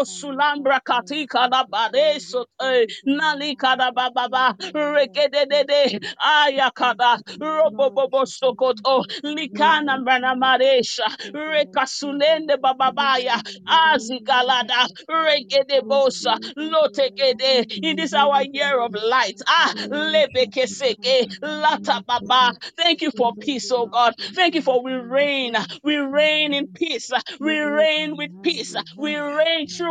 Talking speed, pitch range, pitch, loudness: 110 wpm, 255-300 Hz, 275 Hz, -19 LUFS